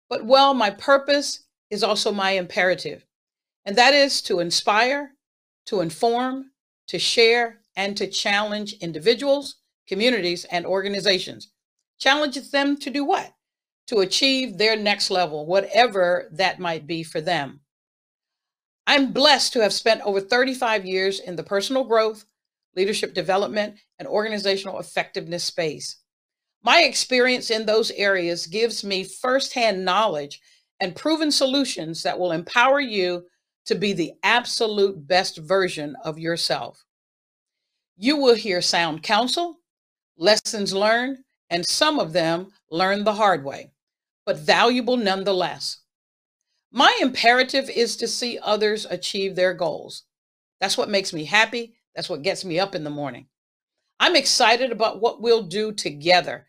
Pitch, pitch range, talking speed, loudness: 210 Hz, 185-245 Hz, 135 wpm, -21 LUFS